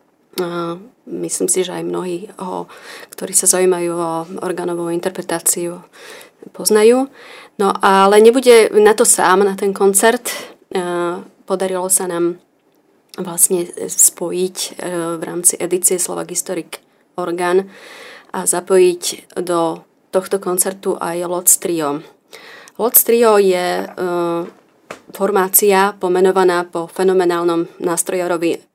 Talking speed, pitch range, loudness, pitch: 100 wpm, 175-195 Hz, -15 LUFS, 185 Hz